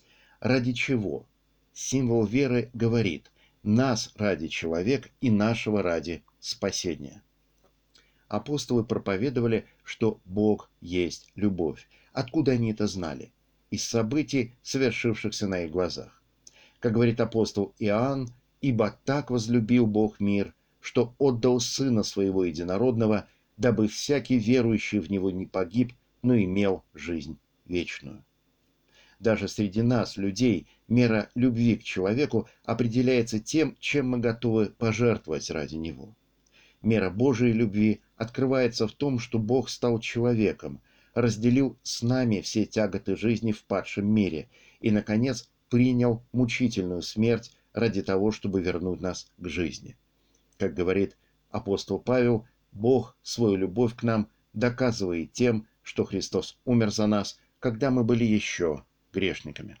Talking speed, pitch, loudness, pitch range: 120 wpm, 115 Hz, -27 LUFS, 100-125 Hz